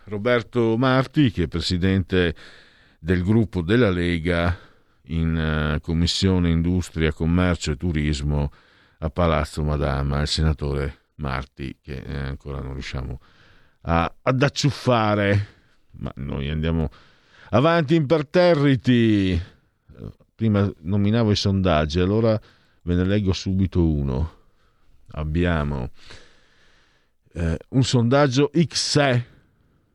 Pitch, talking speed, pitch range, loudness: 90 Hz, 100 wpm, 75-110 Hz, -22 LUFS